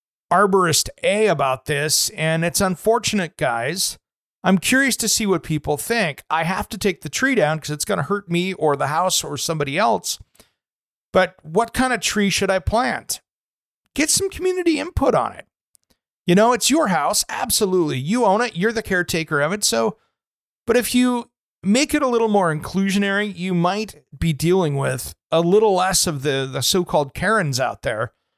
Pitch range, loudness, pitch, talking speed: 160-220 Hz, -19 LUFS, 185 Hz, 185 wpm